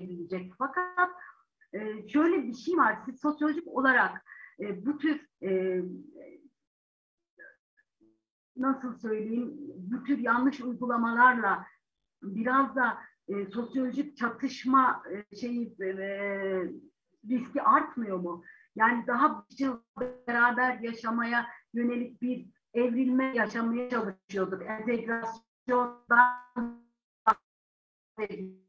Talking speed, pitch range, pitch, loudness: 75 wpm, 220-270 Hz, 240 Hz, -29 LUFS